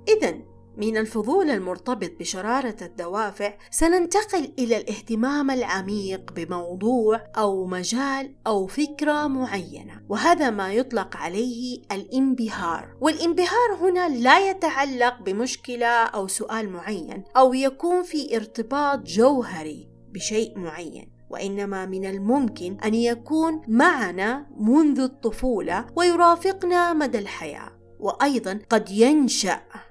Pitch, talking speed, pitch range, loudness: 240 Hz, 100 wpm, 205-290 Hz, -23 LUFS